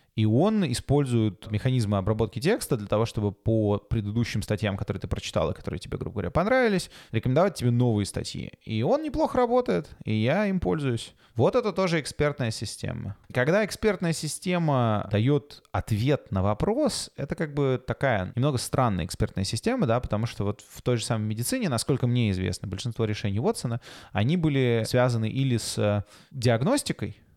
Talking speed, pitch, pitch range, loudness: 160 wpm, 120 Hz, 105-145 Hz, -26 LUFS